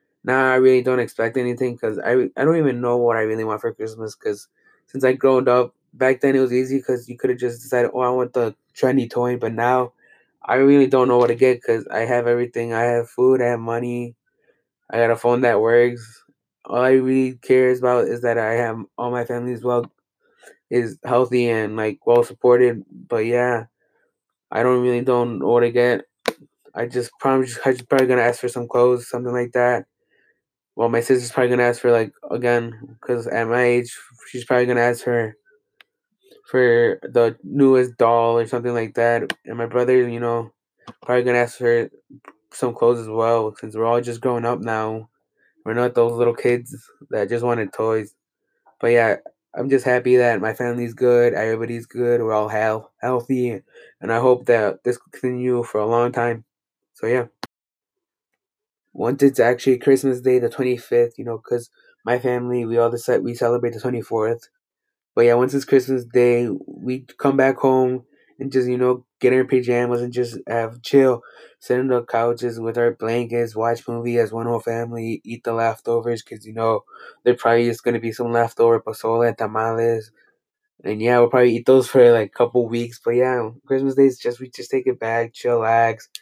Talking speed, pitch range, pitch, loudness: 200 wpm, 115-125 Hz, 120 Hz, -19 LUFS